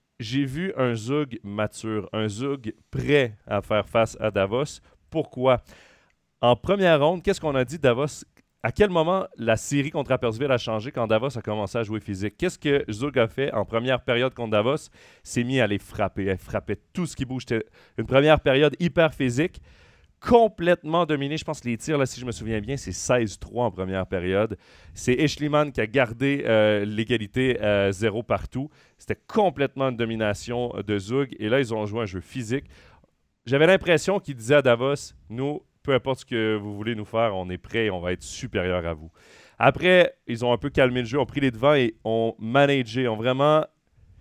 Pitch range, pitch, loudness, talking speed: 110-140 Hz, 120 Hz, -24 LUFS, 205 wpm